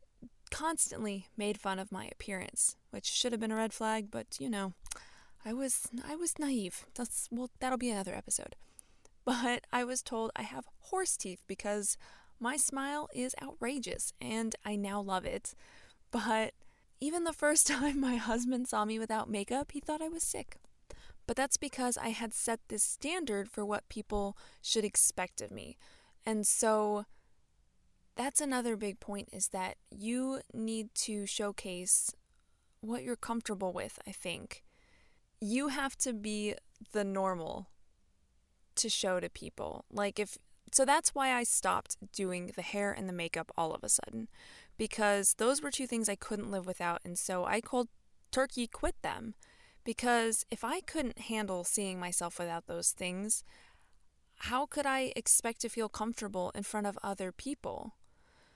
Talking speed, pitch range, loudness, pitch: 165 wpm, 200-250 Hz, -34 LUFS, 220 Hz